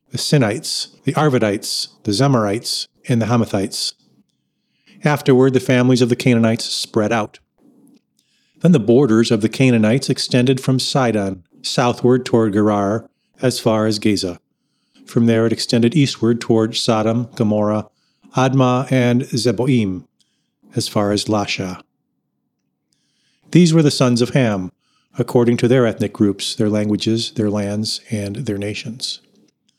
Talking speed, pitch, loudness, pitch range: 135 wpm, 115 Hz, -17 LUFS, 105-130 Hz